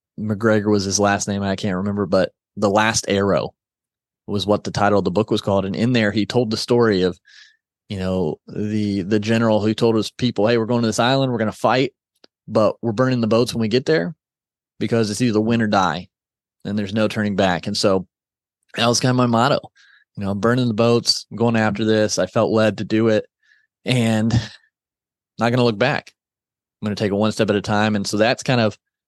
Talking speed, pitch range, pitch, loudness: 230 wpm, 105-115 Hz, 110 Hz, -19 LUFS